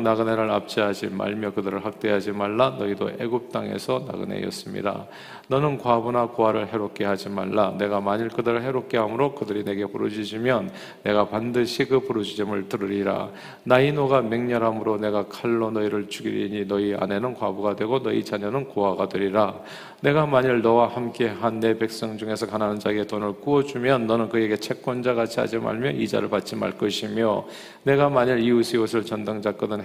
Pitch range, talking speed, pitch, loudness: 105-120 Hz, 390 characters per minute, 110 Hz, -24 LUFS